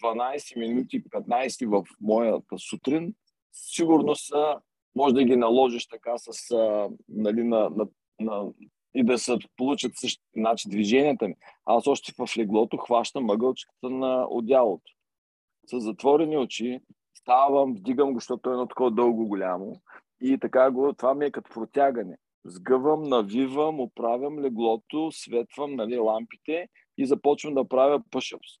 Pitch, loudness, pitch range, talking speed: 125 Hz, -26 LUFS, 115-140 Hz, 140 wpm